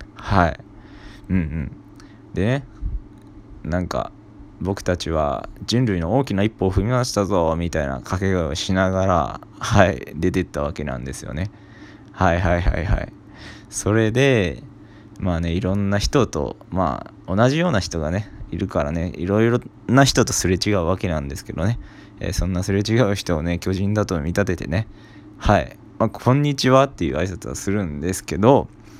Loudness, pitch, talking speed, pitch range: -21 LUFS, 100 Hz, 325 characters per minute, 90-105 Hz